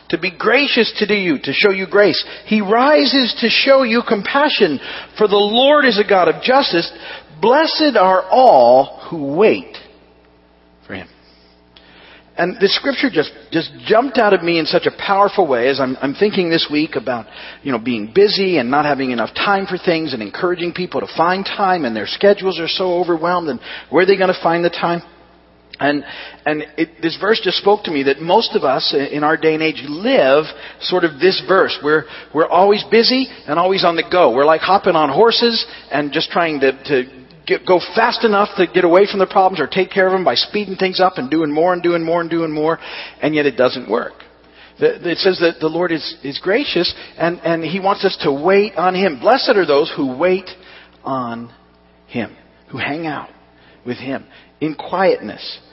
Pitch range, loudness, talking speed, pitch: 150-205 Hz, -15 LUFS, 205 wpm, 180 Hz